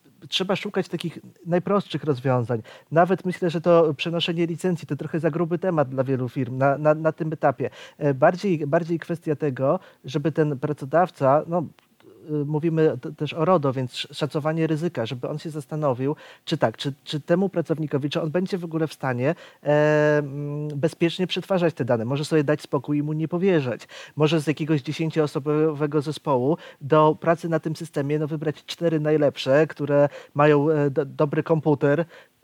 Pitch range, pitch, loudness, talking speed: 145-170 Hz, 155 Hz, -23 LUFS, 165 wpm